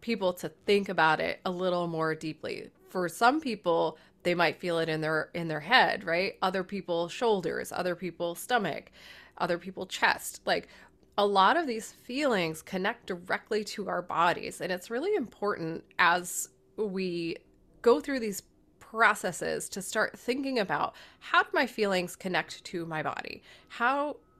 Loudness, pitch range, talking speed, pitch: -30 LUFS, 170-225 Hz, 160 wpm, 185 Hz